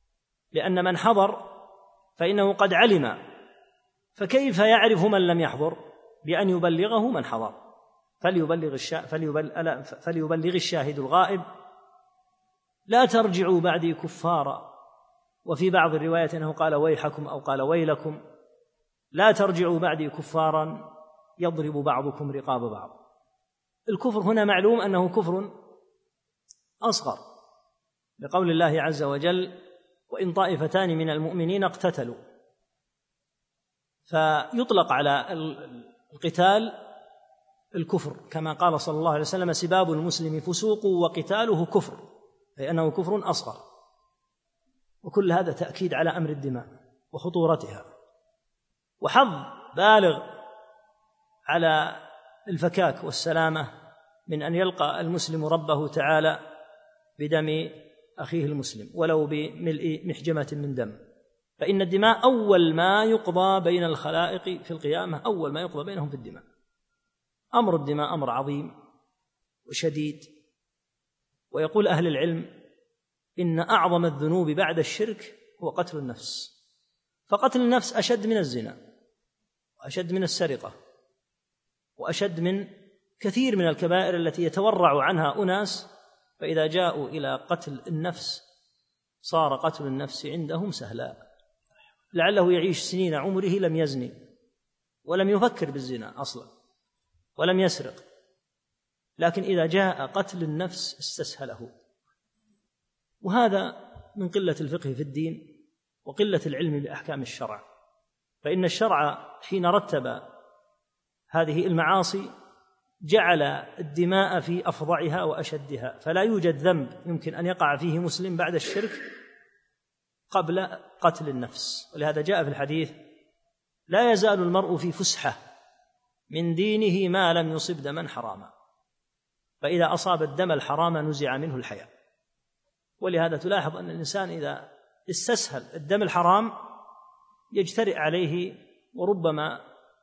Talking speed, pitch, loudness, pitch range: 105 wpm, 175 Hz, -25 LUFS, 155-200 Hz